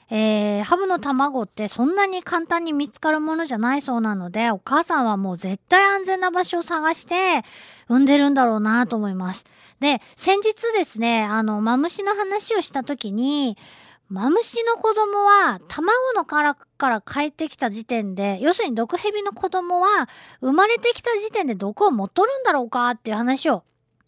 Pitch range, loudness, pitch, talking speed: 230-375 Hz, -21 LUFS, 285 Hz, 340 characters per minute